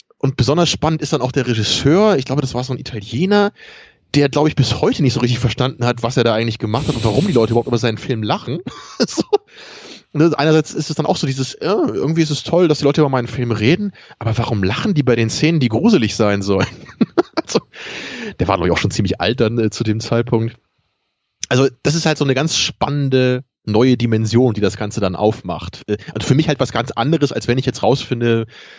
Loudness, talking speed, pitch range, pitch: -17 LUFS, 235 wpm, 115-145 Hz, 125 Hz